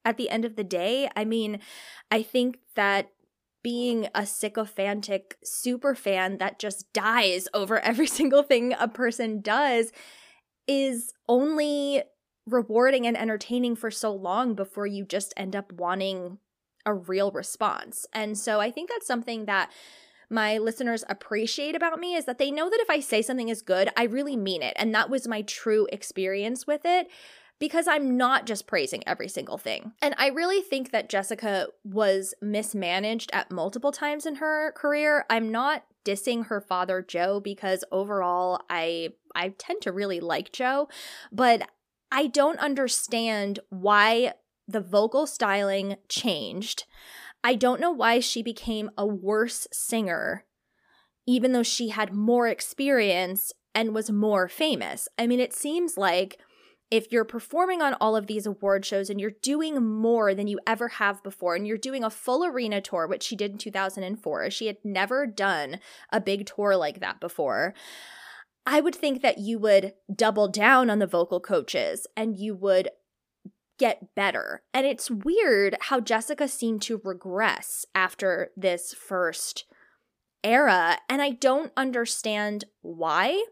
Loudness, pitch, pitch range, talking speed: -26 LUFS, 220 Hz, 200-260 Hz, 160 wpm